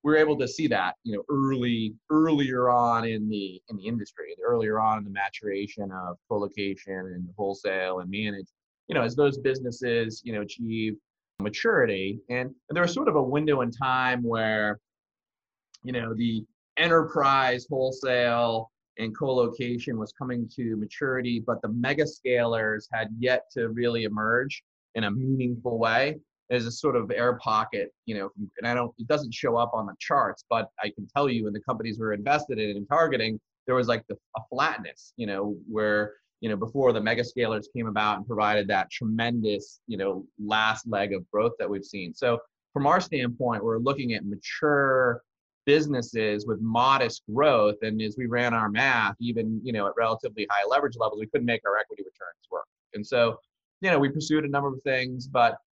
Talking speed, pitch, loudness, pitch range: 190 wpm, 115 Hz, -27 LUFS, 105-130 Hz